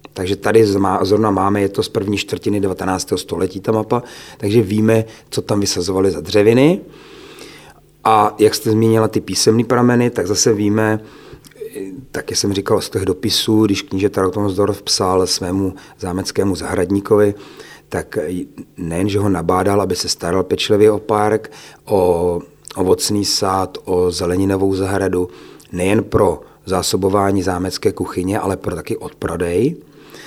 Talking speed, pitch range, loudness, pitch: 140 wpm, 95-110 Hz, -17 LUFS, 100 Hz